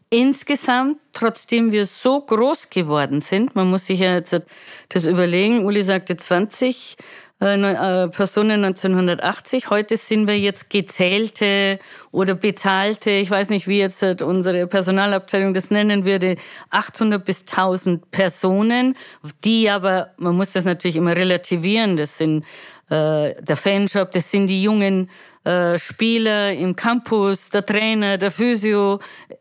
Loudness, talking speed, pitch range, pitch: -19 LUFS, 140 wpm, 185-210 Hz, 195 Hz